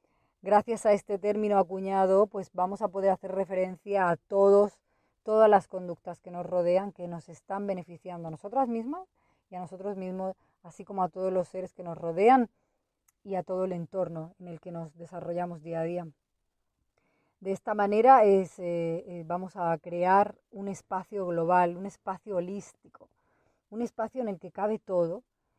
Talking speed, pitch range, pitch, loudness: 170 wpm, 175-200 Hz, 190 Hz, -28 LUFS